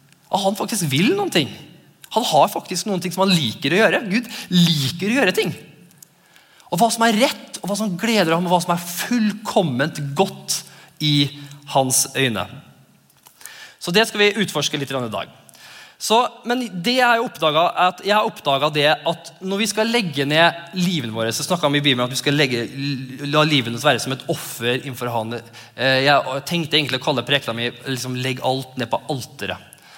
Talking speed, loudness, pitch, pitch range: 185 wpm, -19 LUFS, 155 Hz, 135-195 Hz